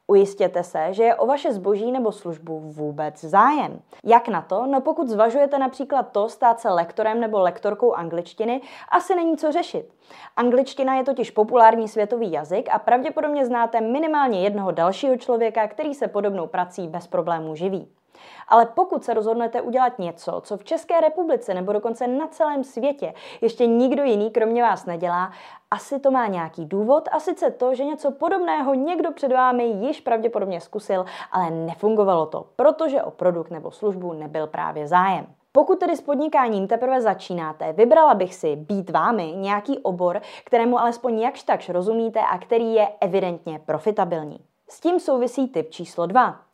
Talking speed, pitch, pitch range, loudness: 165 wpm, 230 Hz, 185-270 Hz, -21 LUFS